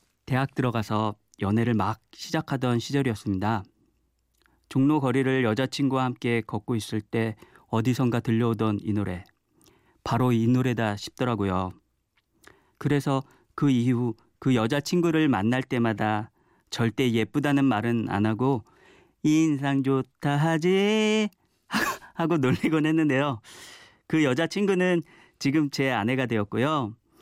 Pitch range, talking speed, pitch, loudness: 110-140 Hz, 260 characters per minute, 125 Hz, -26 LUFS